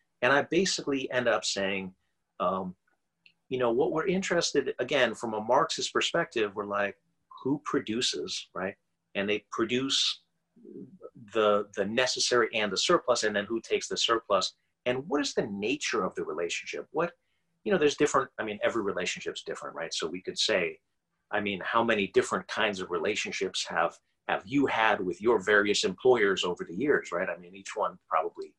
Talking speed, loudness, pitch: 180 wpm, -29 LUFS, 175 Hz